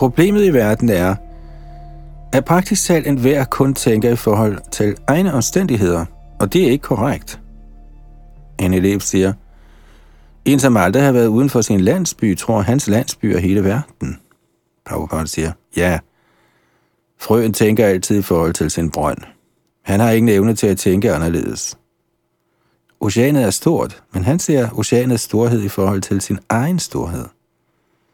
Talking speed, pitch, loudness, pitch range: 155 wpm, 110 Hz, -16 LUFS, 90-130 Hz